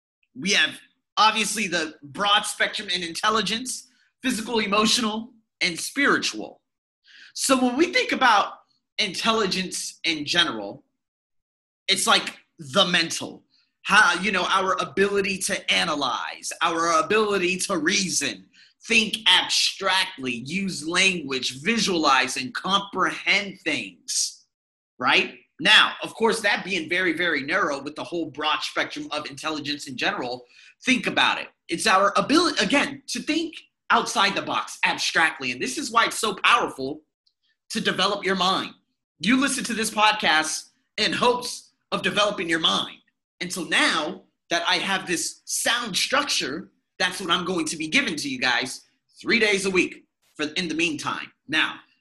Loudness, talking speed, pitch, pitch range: -22 LUFS, 145 wpm, 195 Hz, 170-225 Hz